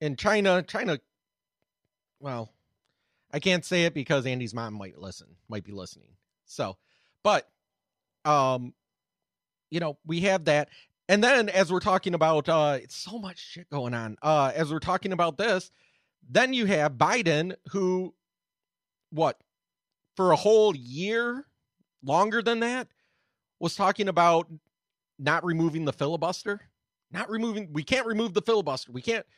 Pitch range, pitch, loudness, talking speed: 150-200 Hz, 170 Hz, -26 LUFS, 145 wpm